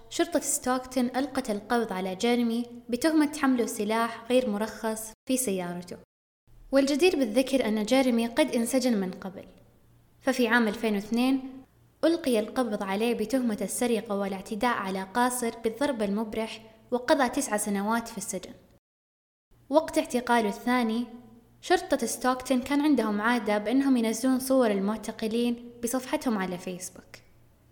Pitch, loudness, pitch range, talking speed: 235 Hz, -27 LUFS, 215-260 Hz, 115 wpm